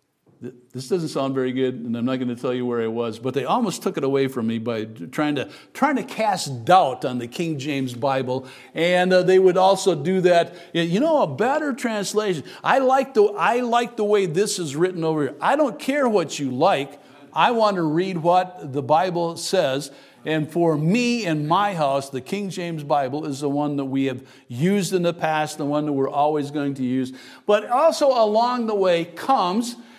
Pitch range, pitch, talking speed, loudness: 135-190 Hz, 160 Hz, 220 wpm, -21 LUFS